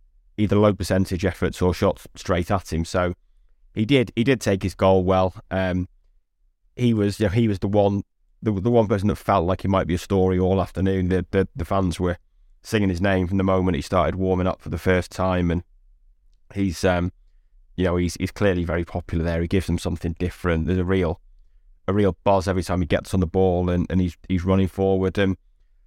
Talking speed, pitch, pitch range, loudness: 225 wpm, 95 Hz, 85-95 Hz, -22 LUFS